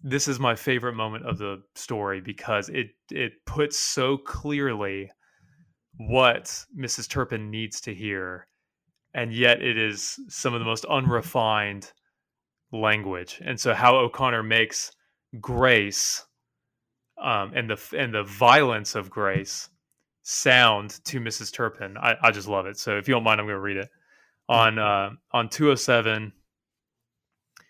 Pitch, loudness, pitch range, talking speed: 115 Hz, -24 LUFS, 105-125 Hz, 145 wpm